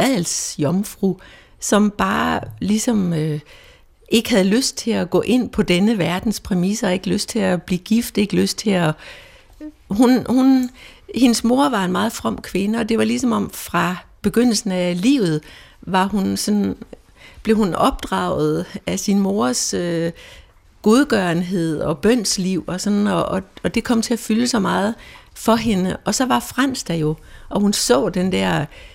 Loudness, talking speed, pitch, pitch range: -19 LUFS, 170 wpm, 205 Hz, 180-230 Hz